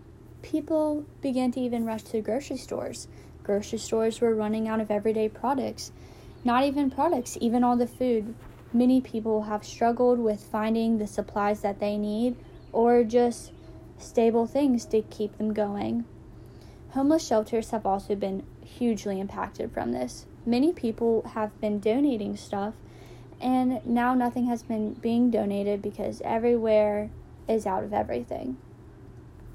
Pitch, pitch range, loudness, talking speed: 220 Hz, 205-245 Hz, -27 LUFS, 140 wpm